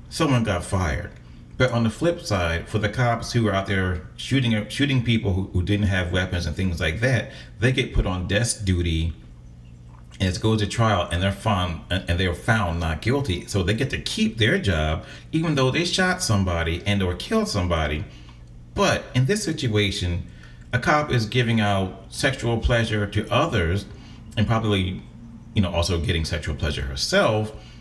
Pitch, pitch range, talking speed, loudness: 105 Hz, 90-115 Hz, 180 wpm, -23 LUFS